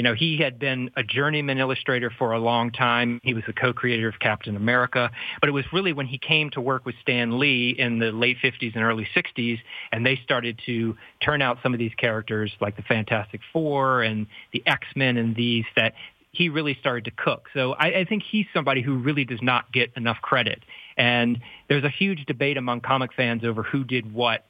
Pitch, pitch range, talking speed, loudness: 125 Hz, 115-135 Hz, 215 wpm, -23 LUFS